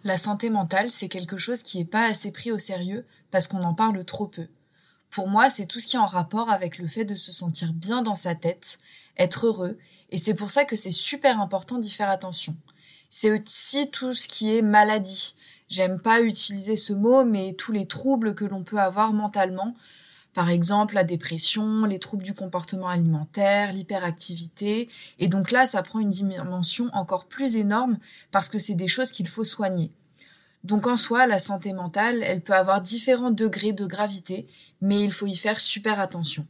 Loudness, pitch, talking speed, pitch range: -22 LUFS, 200 Hz, 195 wpm, 185-220 Hz